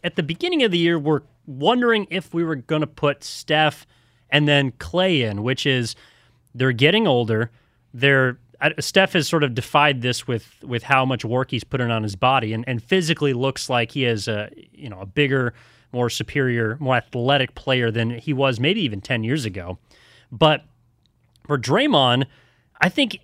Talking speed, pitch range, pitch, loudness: 185 wpm, 120-150 Hz, 130 Hz, -20 LUFS